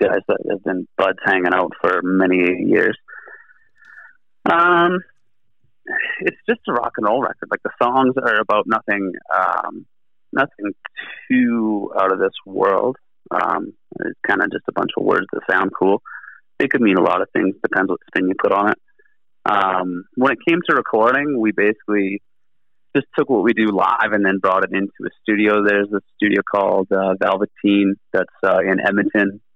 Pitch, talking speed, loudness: 105 Hz, 180 wpm, -18 LUFS